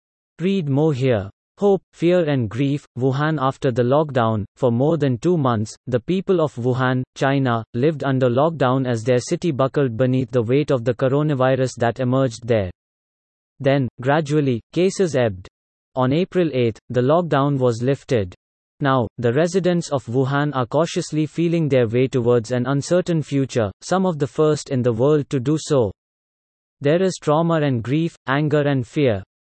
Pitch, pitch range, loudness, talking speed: 135 Hz, 125-155 Hz, -20 LUFS, 165 wpm